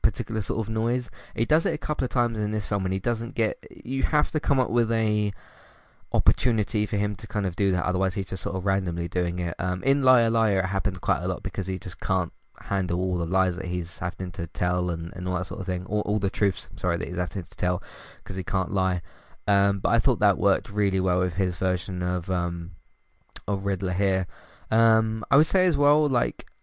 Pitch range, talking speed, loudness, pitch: 90-110 Hz, 240 wpm, -26 LUFS, 95 Hz